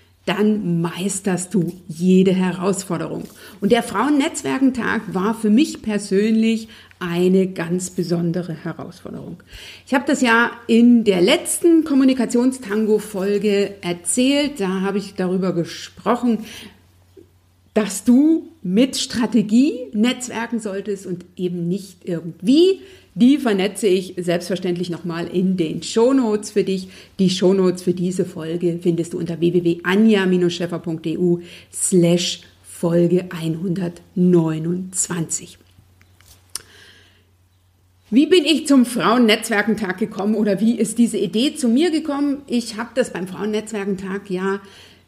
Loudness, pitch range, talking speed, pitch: -19 LUFS, 175-230 Hz, 110 wpm, 195 Hz